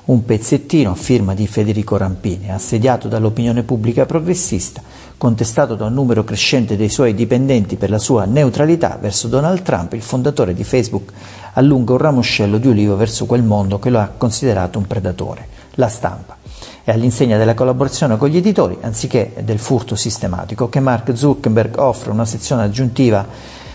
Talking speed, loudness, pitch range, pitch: 160 wpm, -15 LUFS, 105-130 Hz, 115 Hz